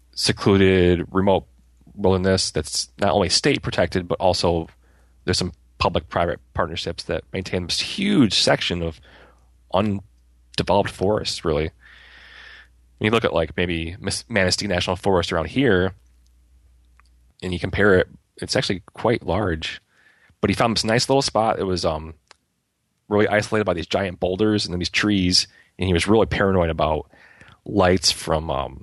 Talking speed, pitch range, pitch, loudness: 150 wpm, 70-100 Hz, 90 Hz, -21 LUFS